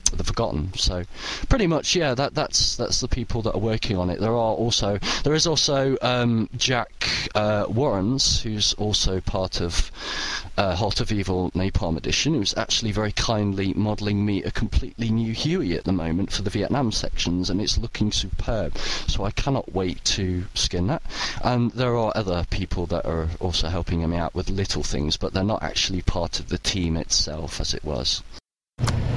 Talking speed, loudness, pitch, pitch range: 185 wpm, -24 LUFS, 100 Hz, 90-115 Hz